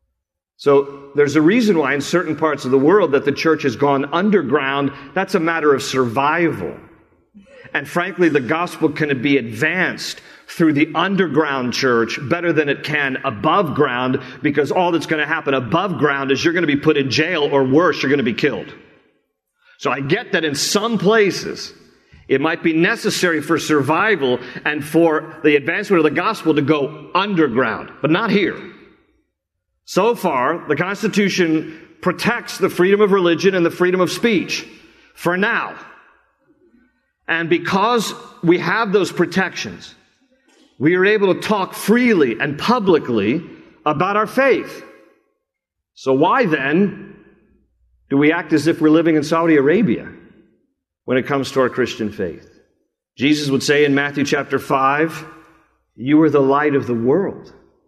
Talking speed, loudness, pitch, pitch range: 160 wpm, -17 LUFS, 155 Hz, 140-180 Hz